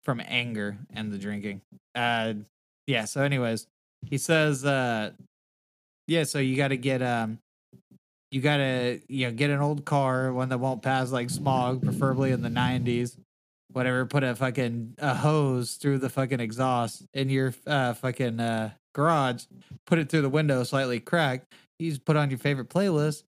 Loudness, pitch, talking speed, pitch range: -27 LUFS, 130 Hz, 170 wpm, 120-140 Hz